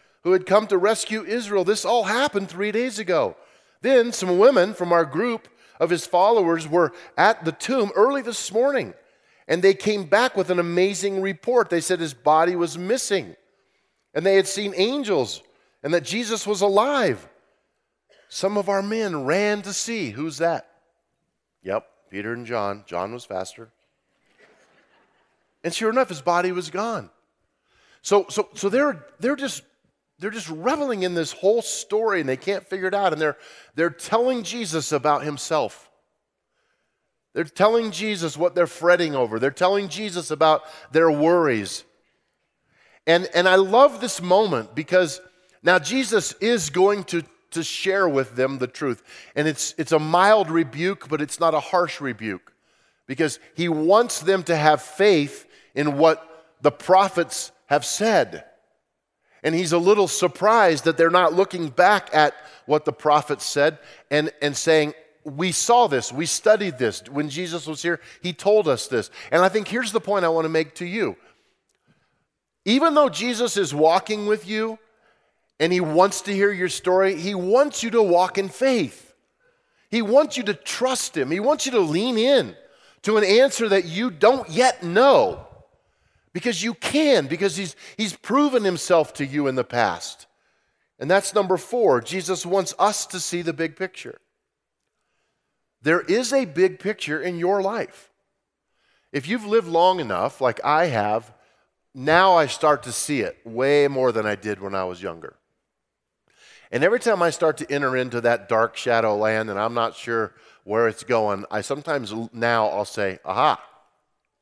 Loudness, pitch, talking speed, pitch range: -21 LUFS, 180 Hz, 170 wpm, 155-215 Hz